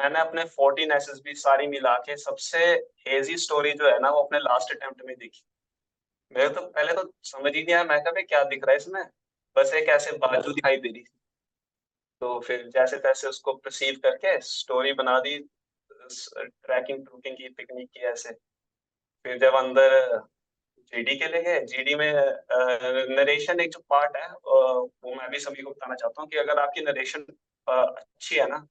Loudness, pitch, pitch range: -24 LUFS, 145 Hz, 130-170 Hz